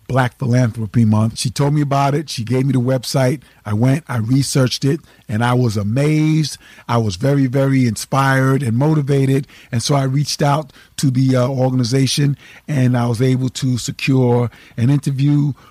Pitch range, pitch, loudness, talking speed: 120-140 Hz, 130 Hz, -17 LUFS, 175 wpm